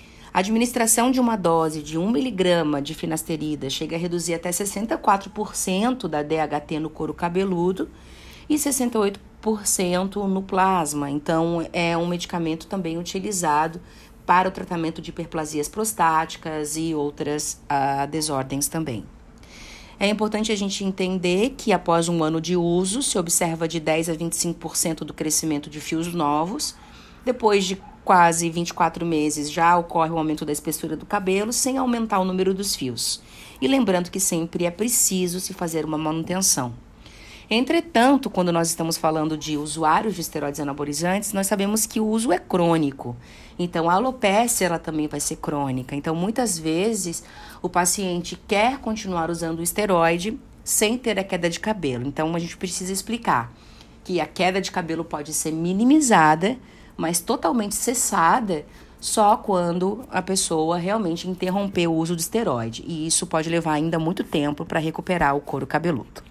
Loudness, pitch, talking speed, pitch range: -23 LUFS, 175 Hz, 155 wpm, 160-200 Hz